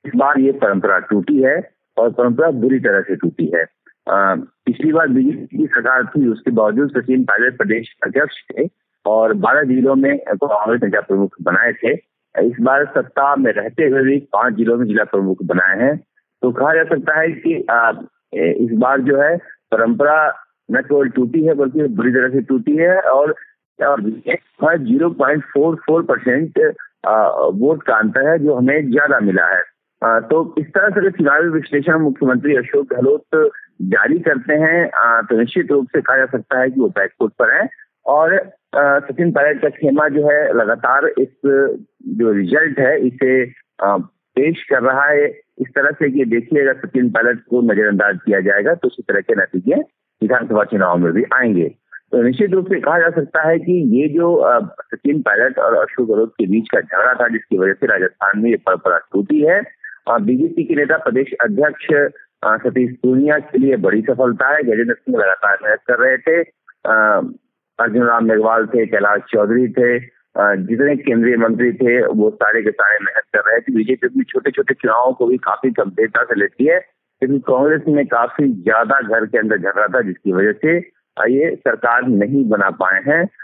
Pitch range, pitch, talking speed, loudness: 125-170 Hz, 140 Hz, 185 wpm, -15 LUFS